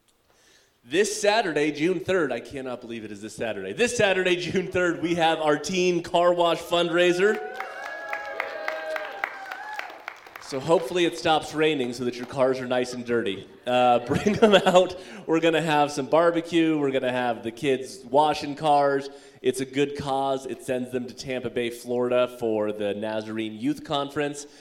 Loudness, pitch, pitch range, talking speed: -25 LUFS, 145 Hz, 125-175 Hz, 170 wpm